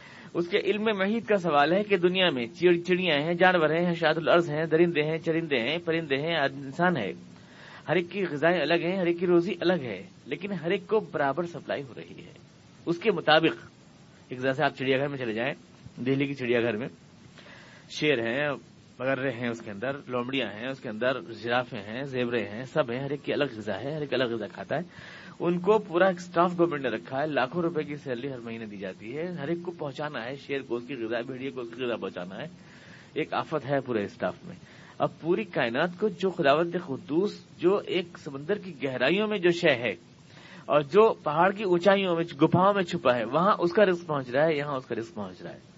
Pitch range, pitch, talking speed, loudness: 135-180 Hz, 155 Hz, 225 wpm, -27 LUFS